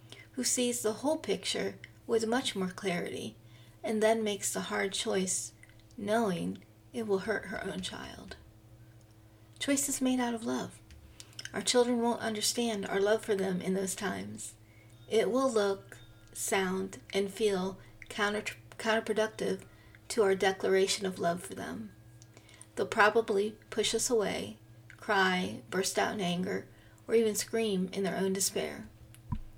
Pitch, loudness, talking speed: 190 Hz, -32 LUFS, 140 wpm